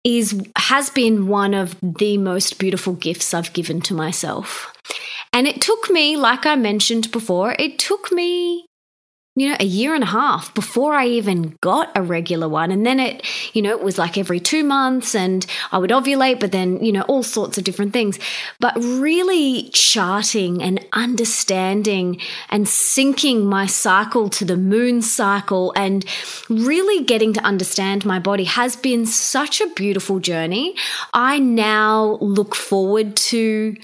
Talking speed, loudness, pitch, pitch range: 165 wpm, -17 LUFS, 215 Hz, 195-255 Hz